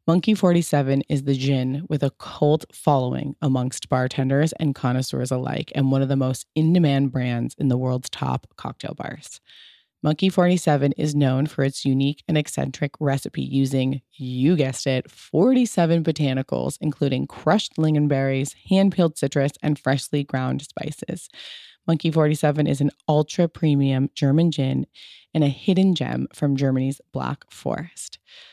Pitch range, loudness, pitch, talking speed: 135-155 Hz, -22 LUFS, 140 Hz, 145 wpm